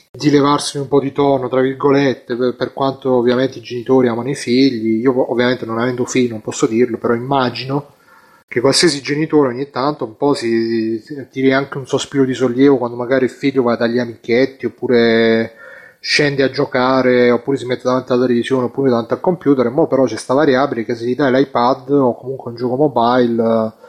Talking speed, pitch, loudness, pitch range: 195 wpm, 130 Hz, -15 LUFS, 120-140 Hz